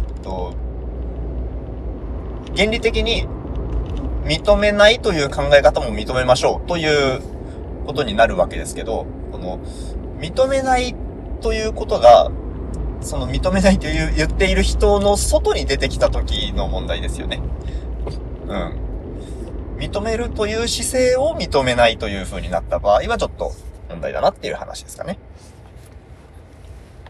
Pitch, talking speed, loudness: 115 Hz, 265 characters per minute, -19 LUFS